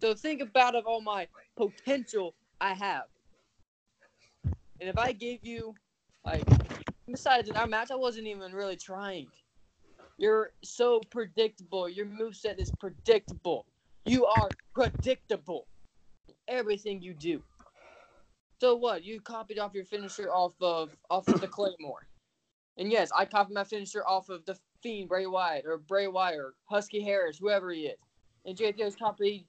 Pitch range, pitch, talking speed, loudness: 190-235 Hz, 205 Hz, 155 wpm, -31 LUFS